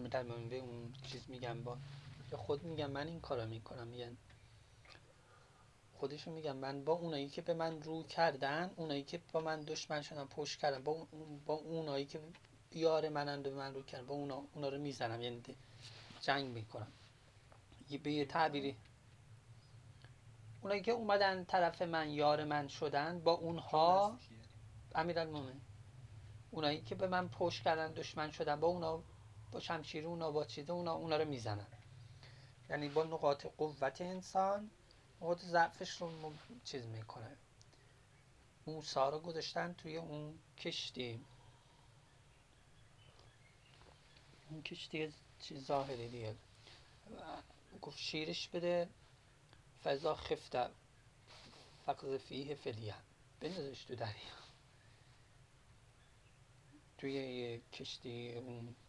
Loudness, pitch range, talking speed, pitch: -41 LUFS, 120-155 Hz, 120 wpm, 135 Hz